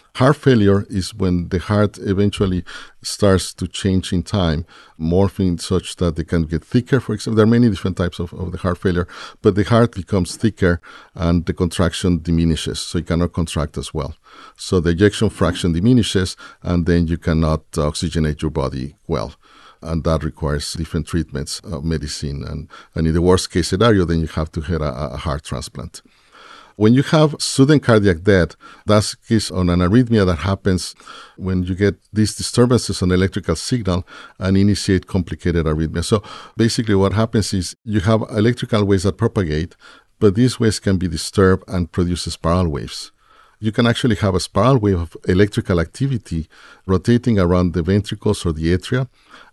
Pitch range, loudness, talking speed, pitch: 85-105 Hz, -18 LUFS, 180 wpm, 95 Hz